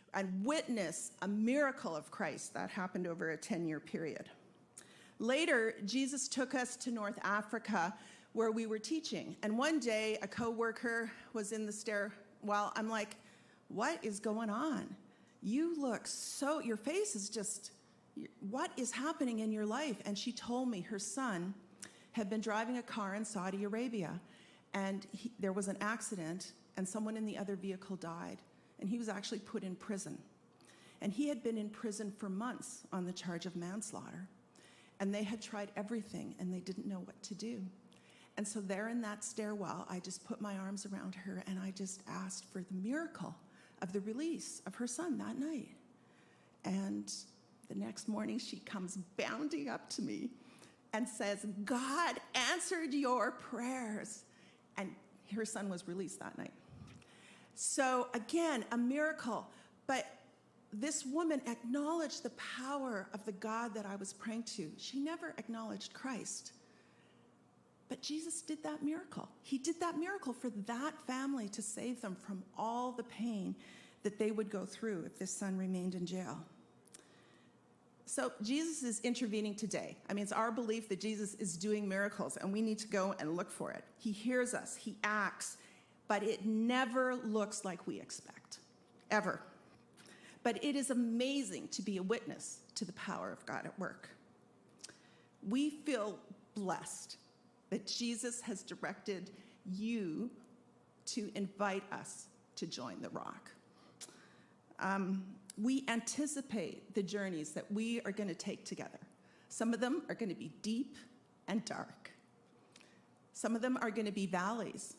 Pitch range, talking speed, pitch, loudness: 200-245 Hz, 160 wpm, 220 Hz, -40 LUFS